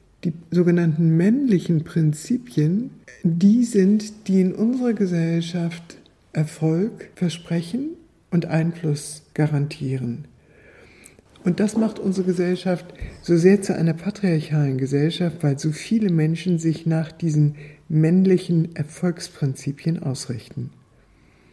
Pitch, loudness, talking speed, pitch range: 170 Hz, -22 LUFS, 100 wpm, 155-185 Hz